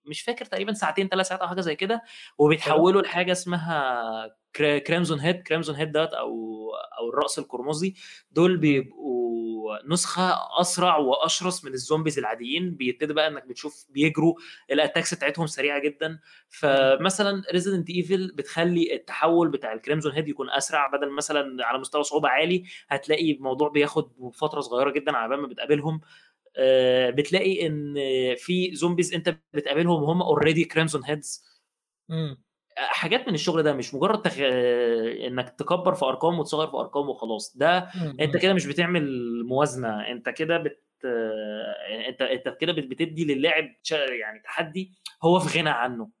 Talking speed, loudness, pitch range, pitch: 140 wpm, -25 LUFS, 135-175 Hz, 155 Hz